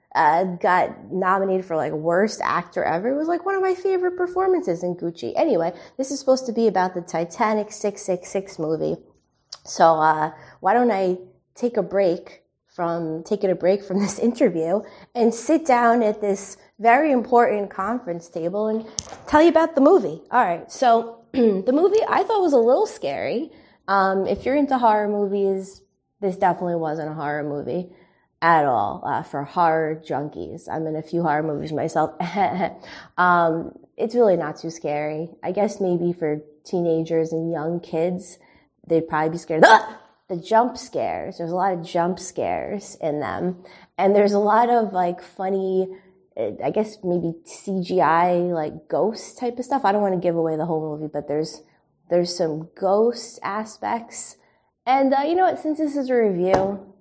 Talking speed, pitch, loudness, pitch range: 175 wpm, 190 Hz, -22 LUFS, 170-230 Hz